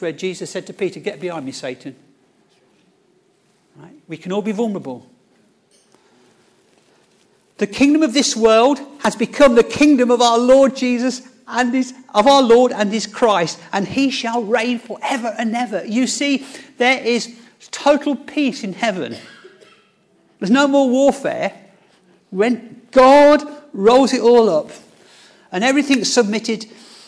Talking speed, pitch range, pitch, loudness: 140 wpm, 210-270 Hz, 235 Hz, -16 LUFS